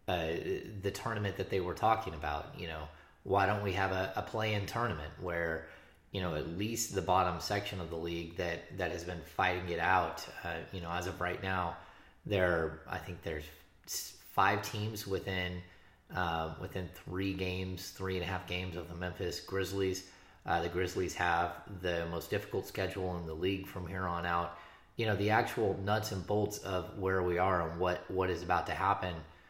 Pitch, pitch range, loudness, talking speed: 90 Hz, 85-95 Hz, -35 LUFS, 200 wpm